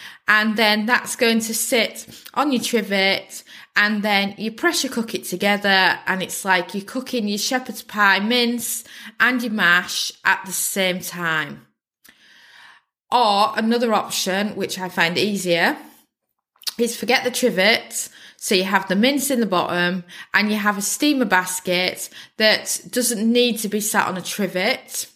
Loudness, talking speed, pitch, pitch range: -19 LUFS, 155 wpm, 210 Hz, 190-235 Hz